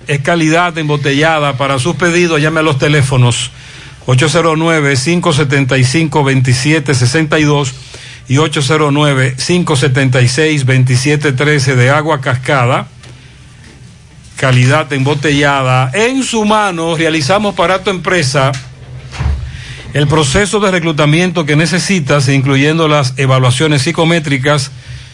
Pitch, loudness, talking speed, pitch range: 150 Hz, -11 LUFS, 85 wpm, 130-160 Hz